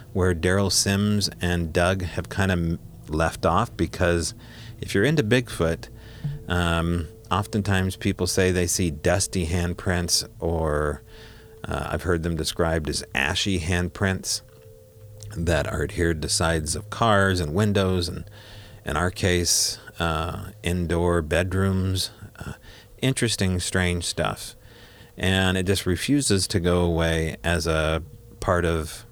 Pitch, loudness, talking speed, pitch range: 95 Hz, -24 LUFS, 130 wpm, 85-105 Hz